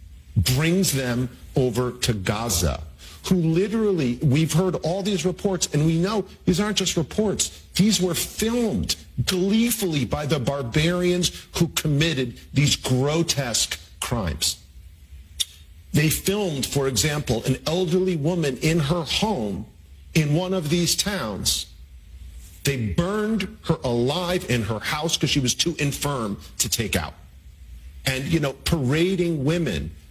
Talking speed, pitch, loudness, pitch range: 130 wpm, 145 Hz, -23 LUFS, 110-175 Hz